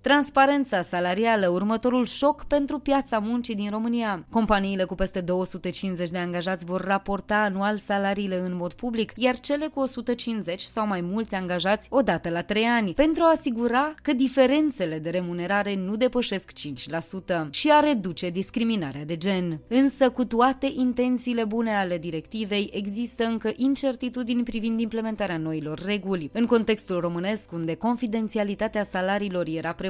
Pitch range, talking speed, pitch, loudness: 185-245 Hz, 145 wpm, 210 Hz, -25 LUFS